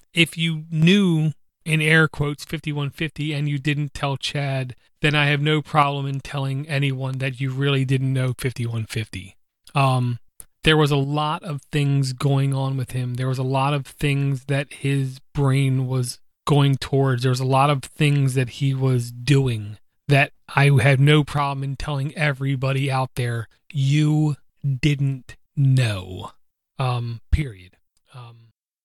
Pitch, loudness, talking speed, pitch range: 135 Hz, -21 LUFS, 155 wpm, 130-145 Hz